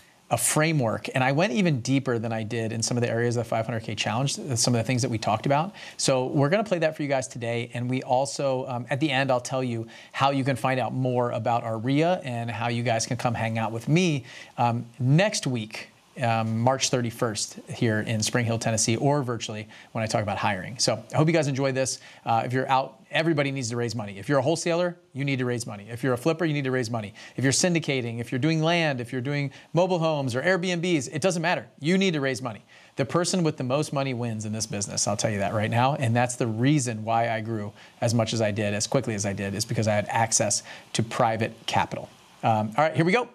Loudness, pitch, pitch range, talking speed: -25 LUFS, 125 Hz, 115-145 Hz, 255 wpm